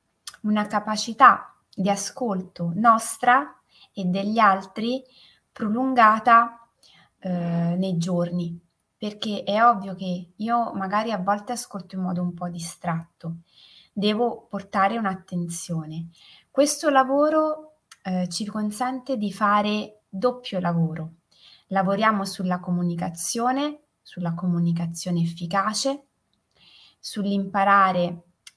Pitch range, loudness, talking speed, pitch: 175-230 Hz, -23 LUFS, 95 wpm, 200 Hz